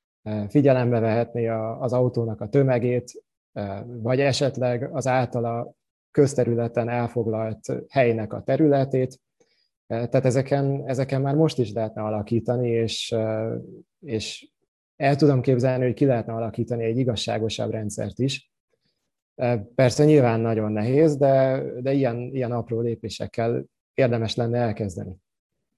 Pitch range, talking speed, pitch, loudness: 115-135 Hz, 115 wpm, 120 Hz, -23 LUFS